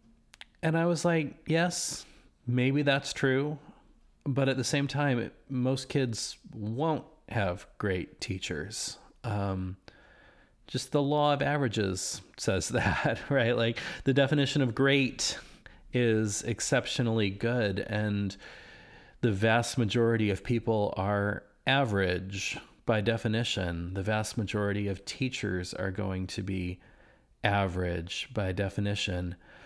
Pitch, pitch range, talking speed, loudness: 115 Hz, 100-135 Hz, 120 wpm, -30 LUFS